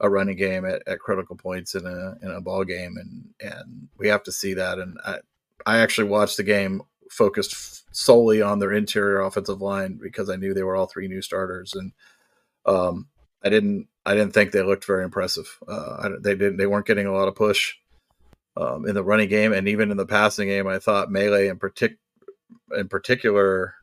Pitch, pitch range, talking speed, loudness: 100 Hz, 95-105 Hz, 210 wpm, -23 LUFS